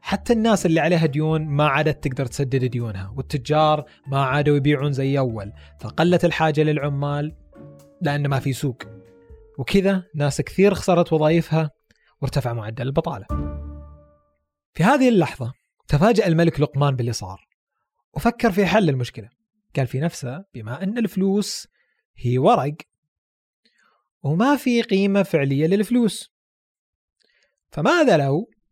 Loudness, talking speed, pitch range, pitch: -21 LUFS, 120 wpm, 130-175 Hz, 150 Hz